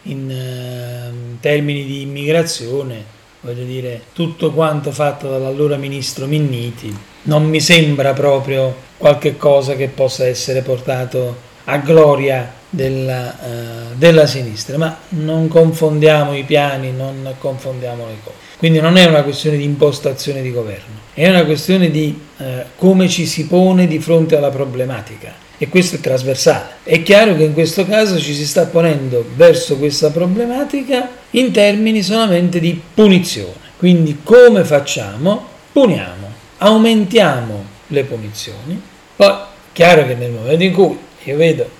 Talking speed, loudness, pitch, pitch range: 140 wpm, -13 LUFS, 145 Hz, 130-170 Hz